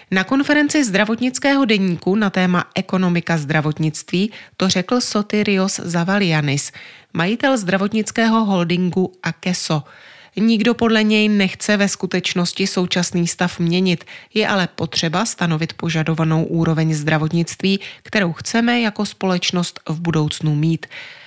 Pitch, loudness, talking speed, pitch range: 185 Hz, -18 LUFS, 110 wpm, 165-210 Hz